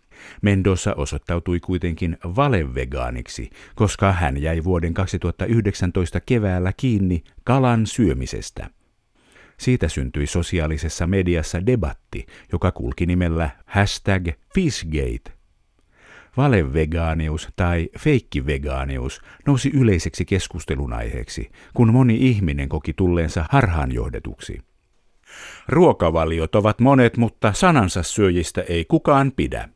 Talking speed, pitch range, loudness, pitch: 90 wpm, 80-105 Hz, -21 LUFS, 90 Hz